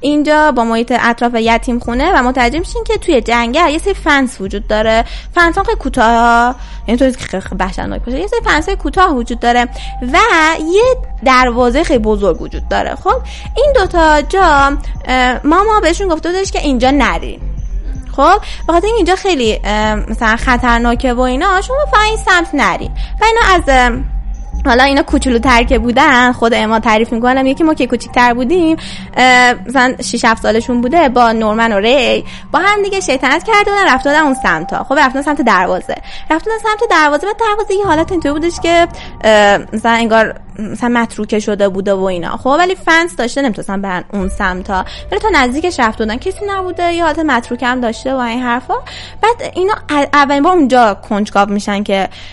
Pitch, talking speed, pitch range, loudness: 260 Hz, 170 wpm, 230-340 Hz, -12 LUFS